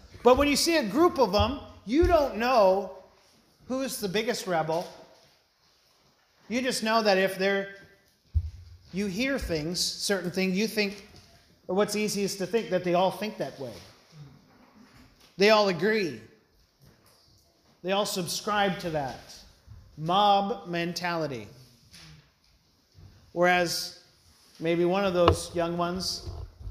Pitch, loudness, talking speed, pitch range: 185 Hz, -26 LUFS, 125 wpm, 155-210 Hz